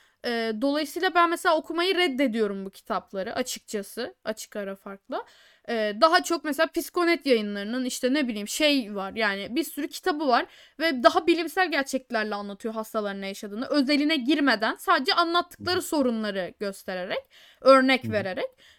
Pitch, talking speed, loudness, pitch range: 265 Hz, 130 wpm, -25 LUFS, 215-325 Hz